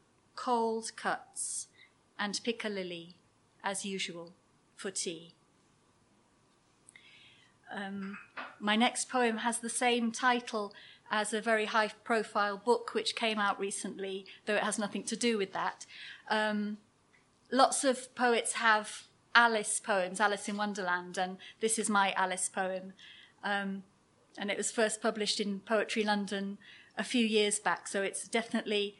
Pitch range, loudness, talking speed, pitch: 195-225 Hz, -32 LUFS, 140 wpm, 210 Hz